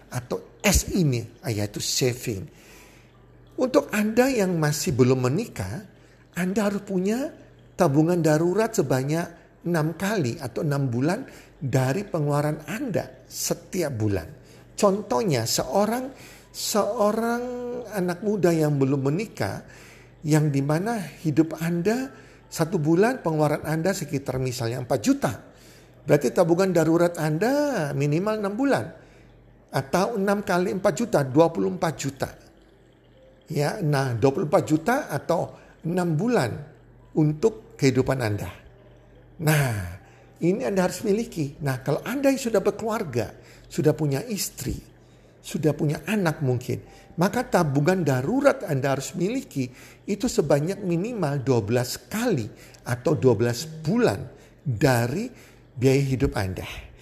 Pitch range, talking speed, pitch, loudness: 135-195 Hz, 115 wpm, 155 Hz, -24 LUFS